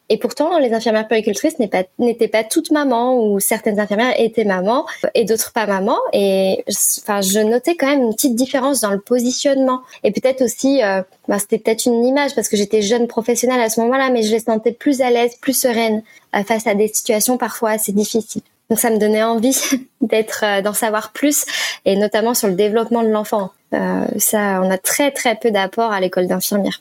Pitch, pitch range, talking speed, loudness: 230 Hz, 215-255 Hz, 210 wpm, -17 LUFS